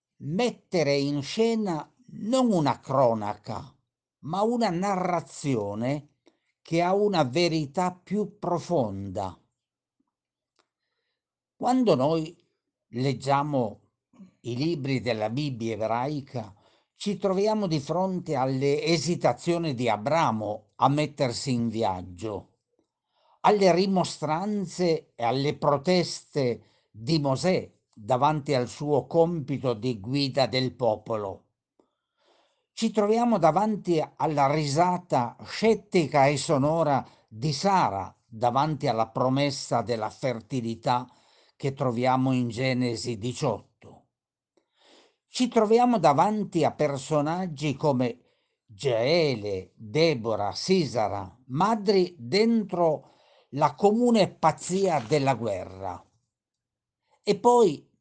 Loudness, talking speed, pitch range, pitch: -26 LUFS, 90 wpm, 125-180 Hz, 145 Hz